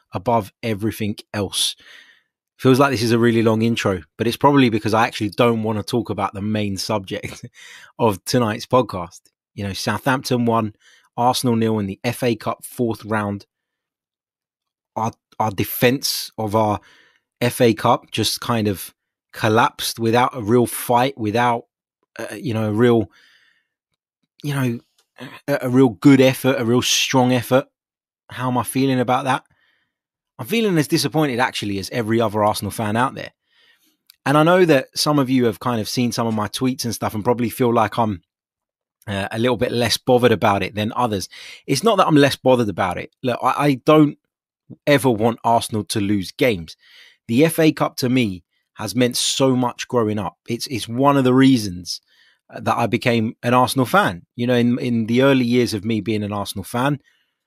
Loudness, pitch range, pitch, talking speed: -19 LUFS, 110-130 Hz, 120 Hz, 185 wpm